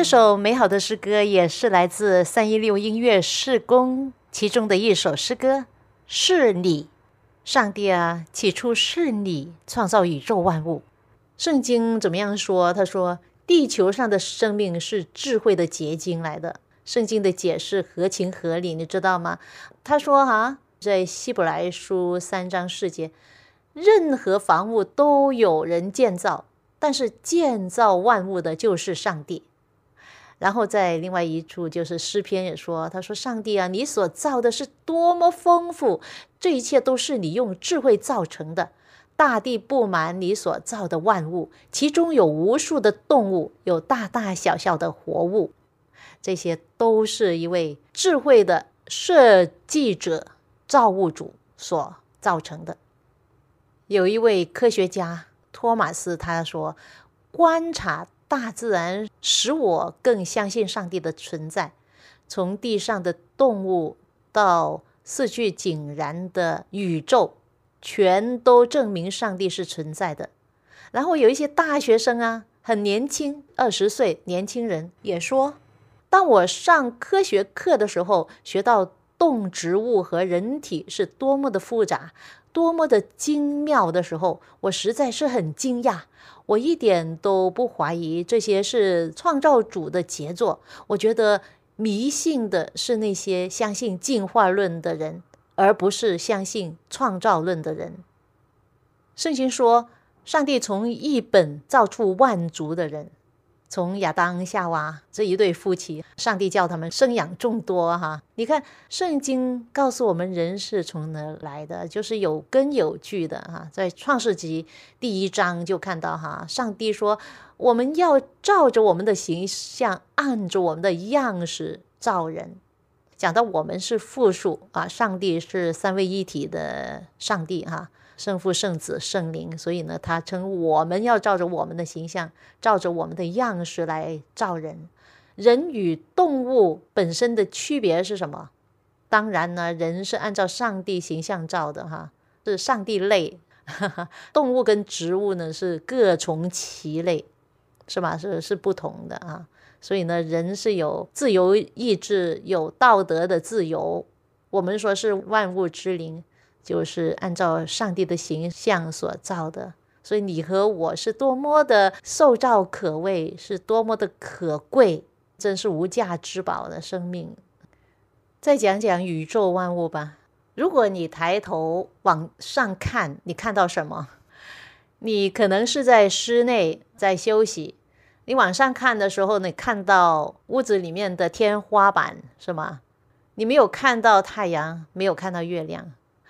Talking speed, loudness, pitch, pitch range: 215 characters per minute, -22 LUFS, 195 Hz, 170-235 Hz